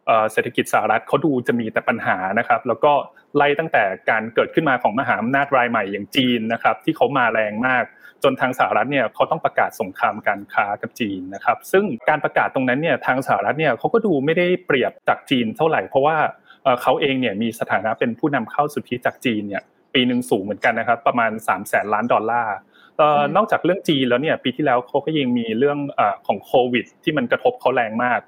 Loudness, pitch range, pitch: -20 LUFS, 120-160 Hz, 135 Hz